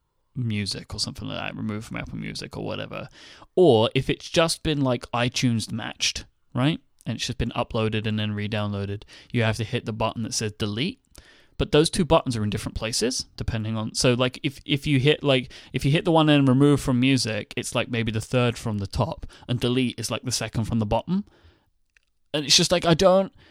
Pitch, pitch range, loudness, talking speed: 120 Hz, 110-140 Hz, -24 LUFS, 220 wpm